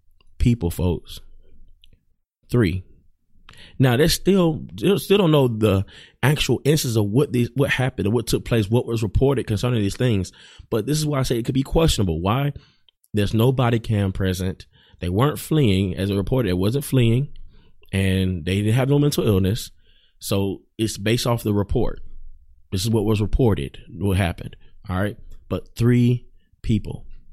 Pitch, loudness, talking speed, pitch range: 110 Hz, -21 LUFS, 170 wpm, 95-130 Hz